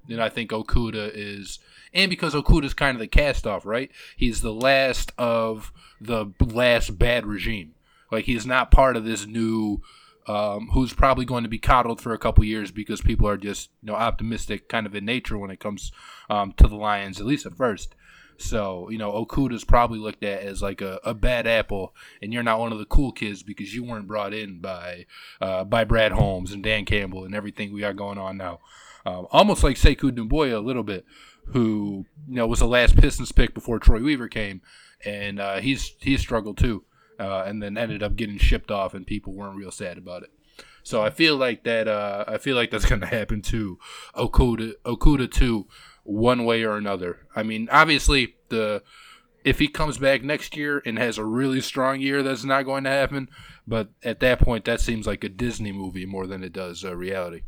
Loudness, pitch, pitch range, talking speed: -24 LUFS, 110 Hz, 100-120 Hz, 210 wpm